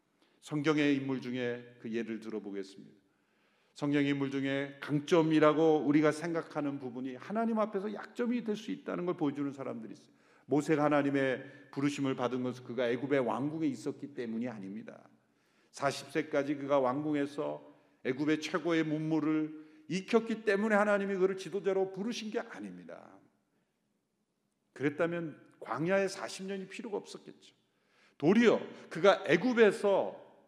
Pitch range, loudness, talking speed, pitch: 135-185 Hz, -32 LUFS, 325 characters per minute, 150 Hz